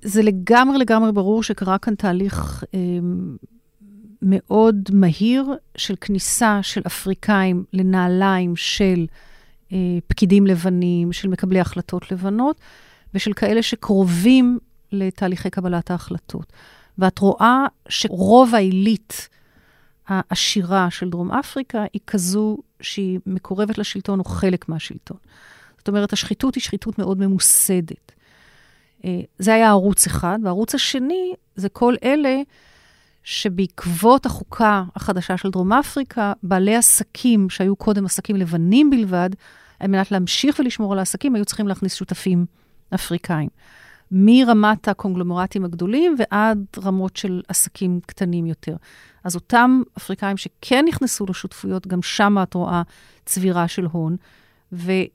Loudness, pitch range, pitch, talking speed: -19 LUFS, 185-215 Hz, 195 Hz, 120 wpm